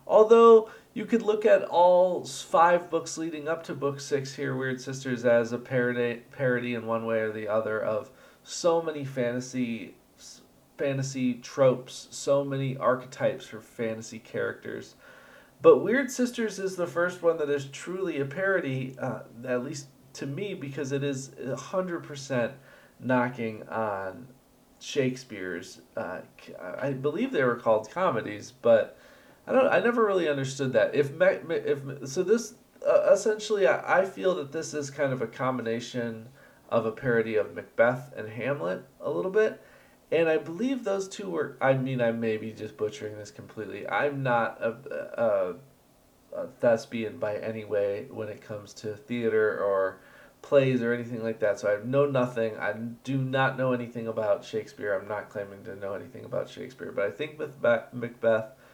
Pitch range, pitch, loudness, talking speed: 115-165 Hz, 130 Hz, -27 LUFS, 170 wpm